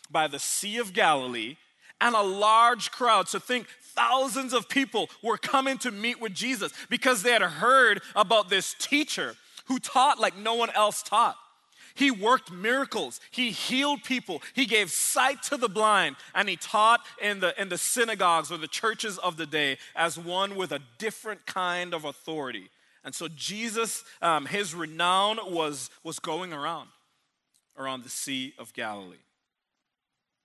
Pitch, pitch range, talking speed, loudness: 210 Hz, 175-245 Hz, 165 wpm, -26 LUFS